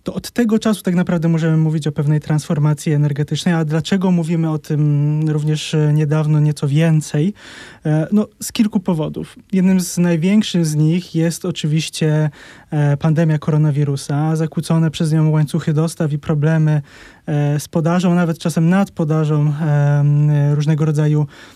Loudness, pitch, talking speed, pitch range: -17 LUFS, 155 Hz, 135 wpm, 150-170 Hz